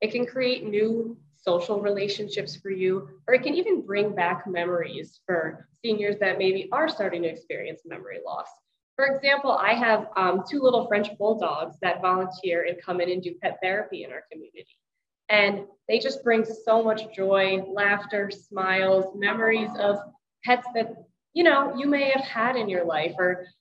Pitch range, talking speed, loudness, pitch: 190-240 Hz, 175 wpm, -25 LUFS, 205 Hz